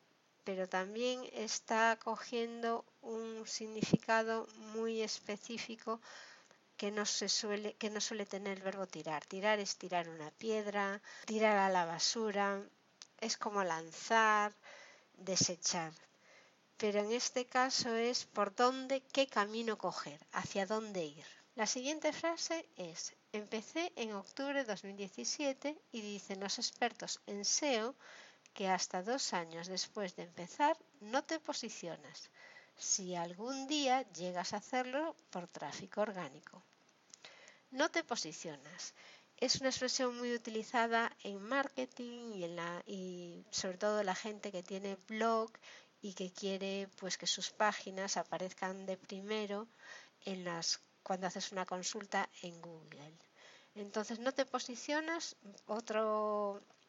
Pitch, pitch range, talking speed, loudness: 210 Hz, 190-235 Hz, 130 wpm, -38 LUFS